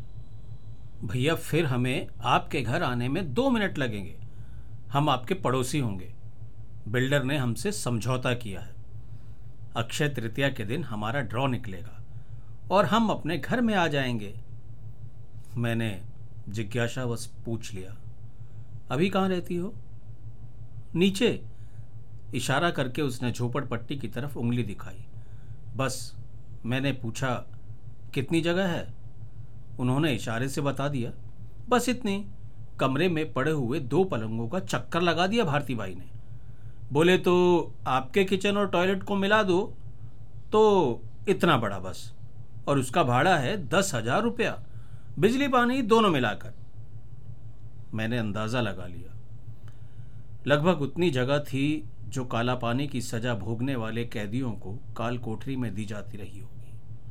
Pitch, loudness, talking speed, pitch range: 120 Hz, -27 LUFS, 130 wpm, 115-145 Hz